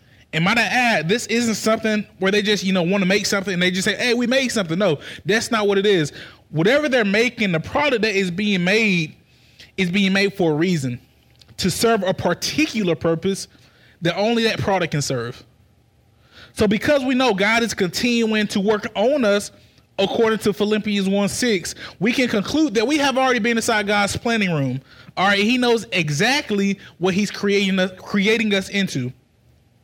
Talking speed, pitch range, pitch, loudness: 195 wpm, 180-225 Hz, 200 Hz, -19 LUFS